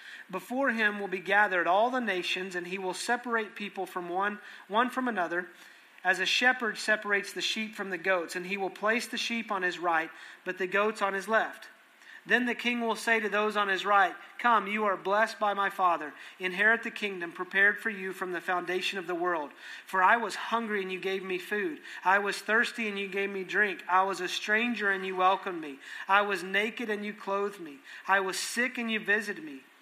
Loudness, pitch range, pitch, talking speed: -29 LUFS, 185-220 Hz, 200 Hz, 220 wpm